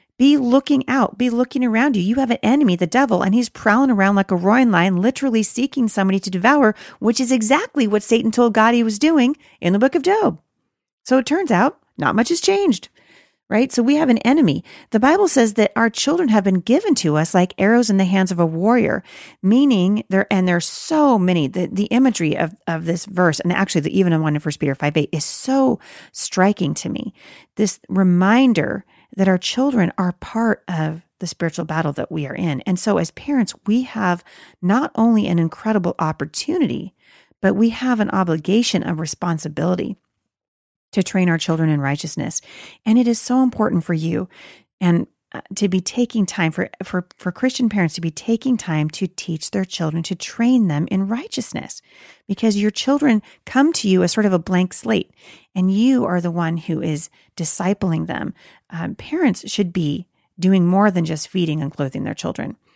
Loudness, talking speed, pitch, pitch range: -18 LUFS, 195 wpm, 200 Hz, 175-245 Hz